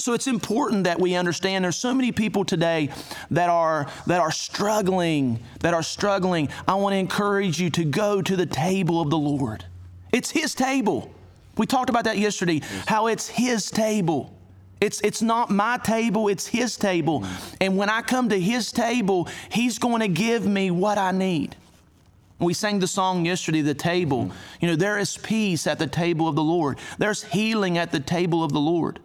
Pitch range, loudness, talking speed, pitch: 165-215 Hz, -23 LUFS, 190 wpm, 185 Hz